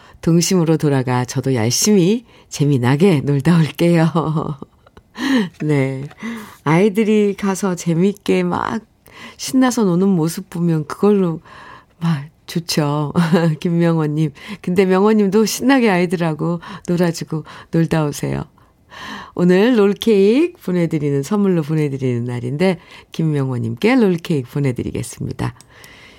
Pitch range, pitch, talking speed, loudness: 145-195 Hz, 170 Hz, 260 characters per minute, -17 LUFS